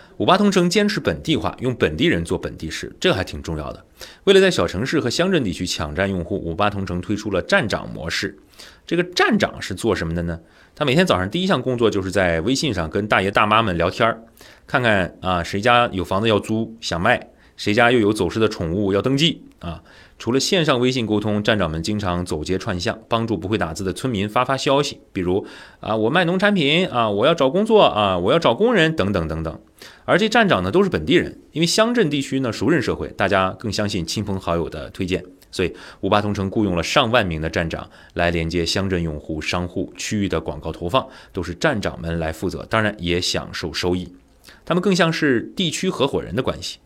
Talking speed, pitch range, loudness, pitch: 325 characters per minute, 90-130 Hz, -20 LUFS, 100 Hz